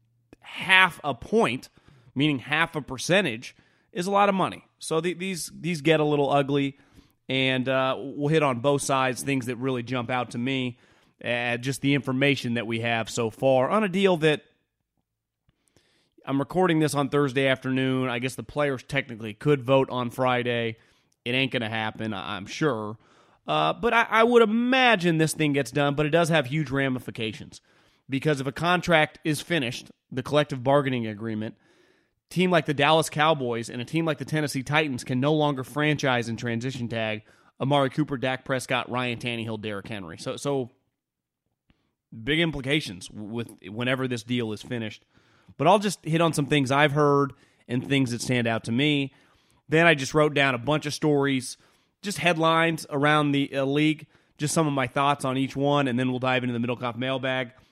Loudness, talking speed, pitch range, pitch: -25 LUFS, 185 wpm, 125-150 Hz, 135 Hz